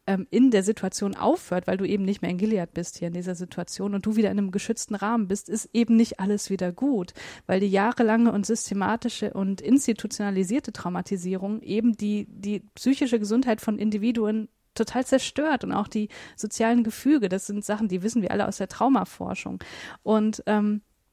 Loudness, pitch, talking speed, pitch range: -25 LUFS, 210 Hz, 180 wpm, 195-230 Hz